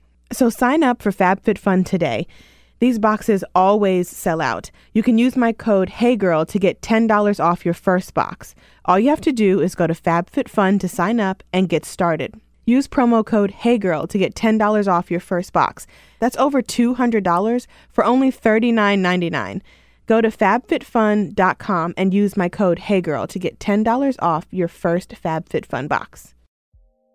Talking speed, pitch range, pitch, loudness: 160 wpm, 175-230 Hz, 200 Hz, -18 LUFS